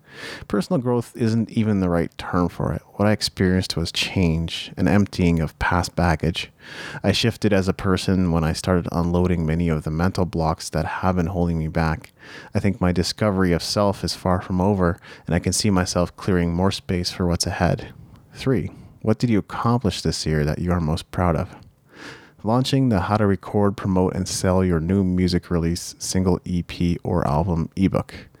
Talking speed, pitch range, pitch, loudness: 190 wpm, 85-105 Hz, 90 Hz, -22 LUFS